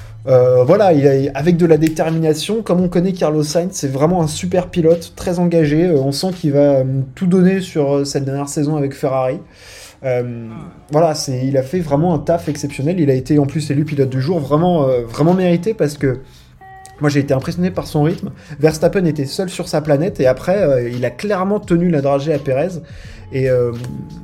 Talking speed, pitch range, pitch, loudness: 215 wpm, 135-175 Hz, 150 Hz, -16 LUFS